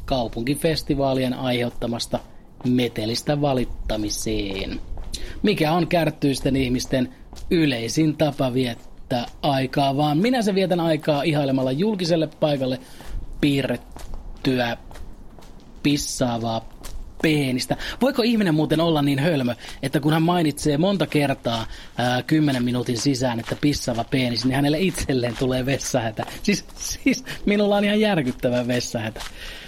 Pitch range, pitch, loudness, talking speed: 120-155 Hz, 135 Hz, -22 LUFS, 110 wpm